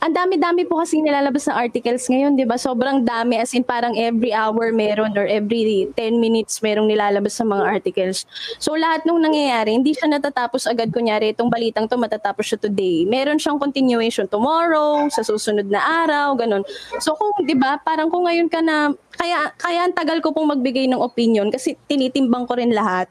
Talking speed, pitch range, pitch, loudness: 195 wpm, 225-310 Hz, 255 Hz, -19 LUFS